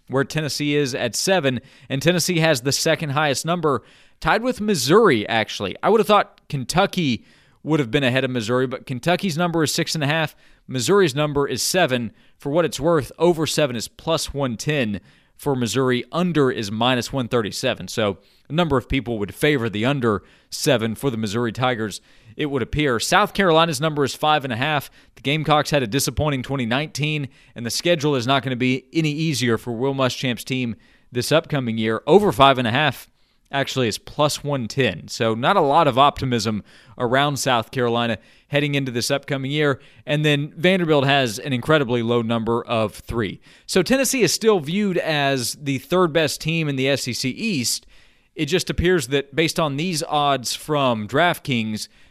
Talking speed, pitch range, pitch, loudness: 185 wpm, 125-155 Hz, 140 Hz, -21 LUFS